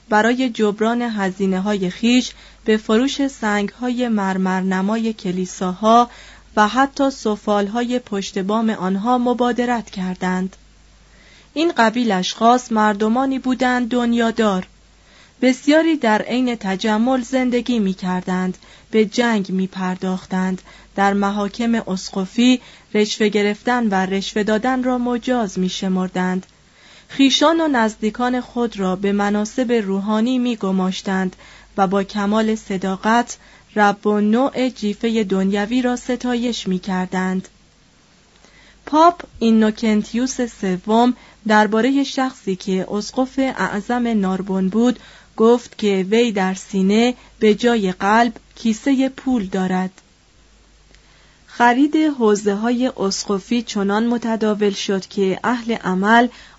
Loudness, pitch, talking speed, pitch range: -19 LUFS, 215 Hz, 110 wpm, 195-245 Hz